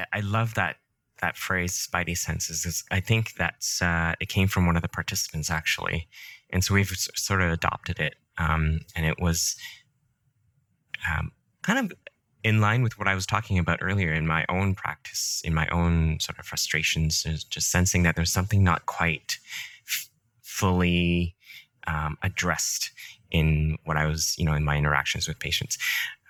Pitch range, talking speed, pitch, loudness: 80-100 Hz, 170 wpm, 85 Hz, -26 LUFS